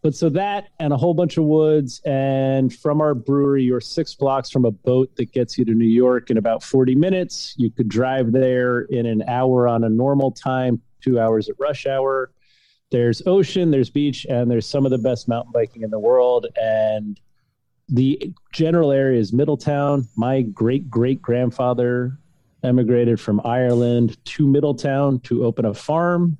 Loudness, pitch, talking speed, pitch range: -19 LUFS, 130 Hz, 180 wpm, 120-145 Hz